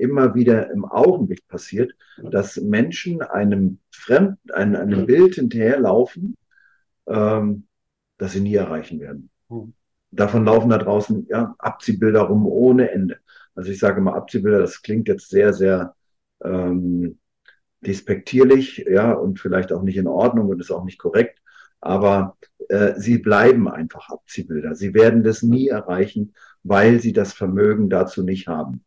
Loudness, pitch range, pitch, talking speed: -18 LUFS, 95-120 Hz, 105 Hz, 145 wpm